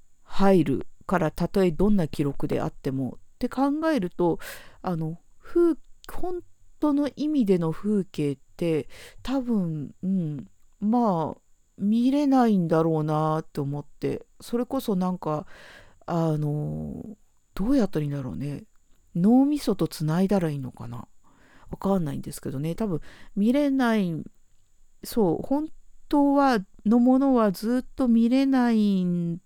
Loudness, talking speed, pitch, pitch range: -25 LUFS, 255 characters per minute, 190 Hz, 155-245 Hz